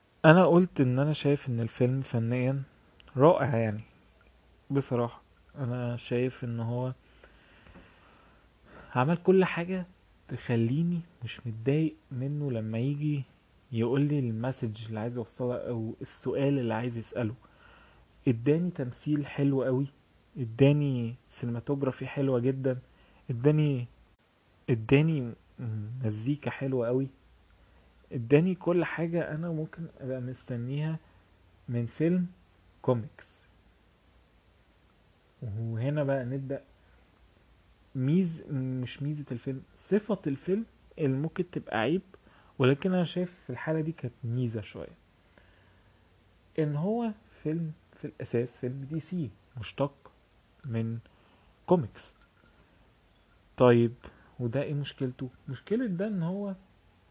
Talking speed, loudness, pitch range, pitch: 105 wpm, -30 LUFS, 115-145 Hz, 130 Hz